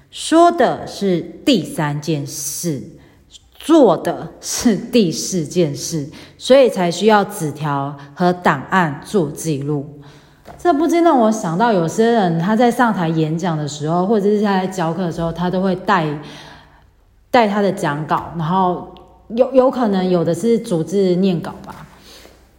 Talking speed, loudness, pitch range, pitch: 210 characters per minute, -17 LUFS, 155-210 Hz, 180 Hz